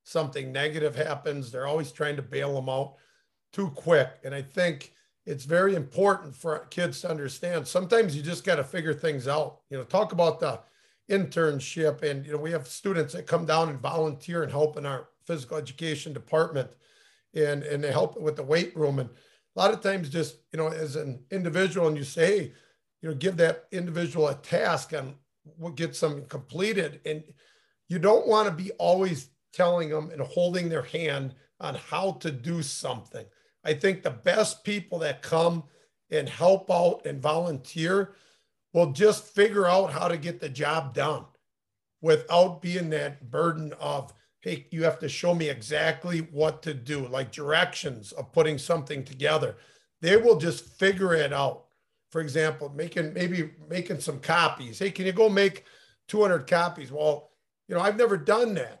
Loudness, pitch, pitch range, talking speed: -27 LUFS, 160 Hz, 150-175 Hz, 180 wpm